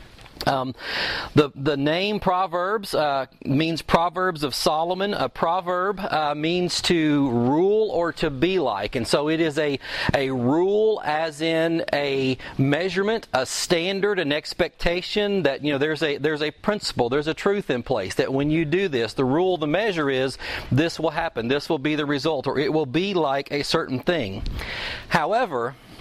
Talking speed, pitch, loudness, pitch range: 175 wpm, 160 Hz, -23 LUFS, 145-180 Hz